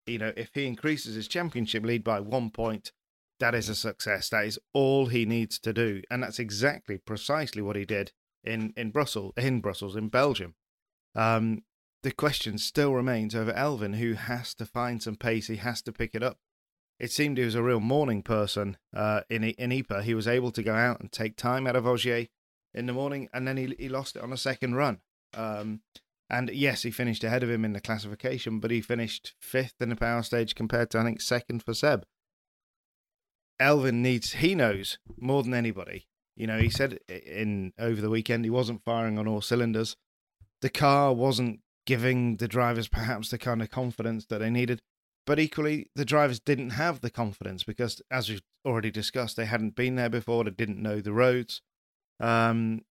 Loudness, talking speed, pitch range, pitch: -29 LUFS, 200 wpm, 110-125 Hz, 115 Hz